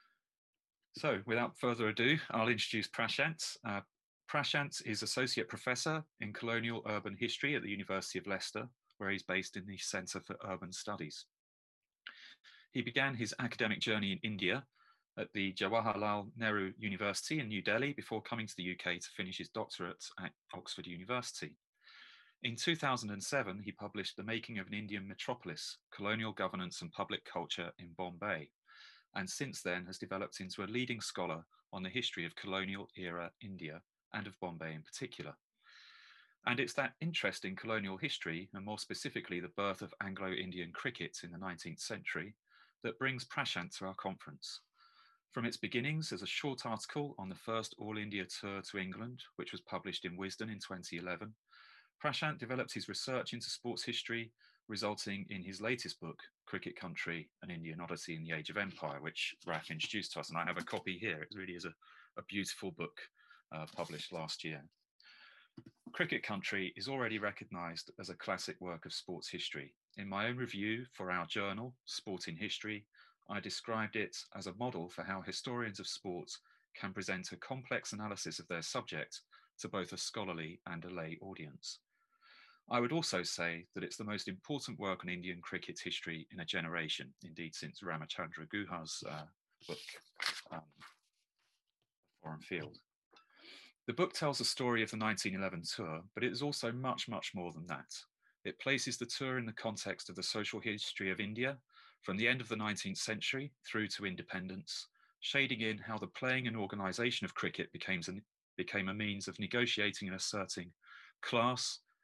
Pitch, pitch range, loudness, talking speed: 105 Hz, 95-120 Hz, -40 LUFS, 170 wpm